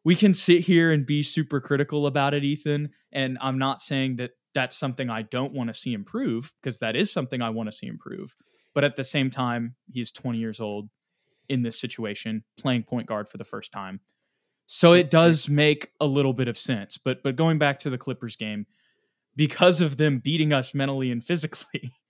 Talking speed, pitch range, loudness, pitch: 210 wpm, 120-150 Hz, -24 LUFS, 135 Hz